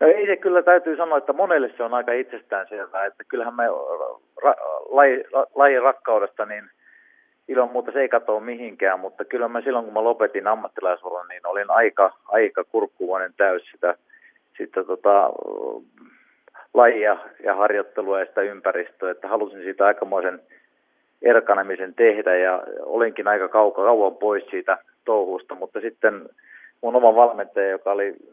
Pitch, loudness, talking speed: 195 Hz, -21 LUFS, 150 wpm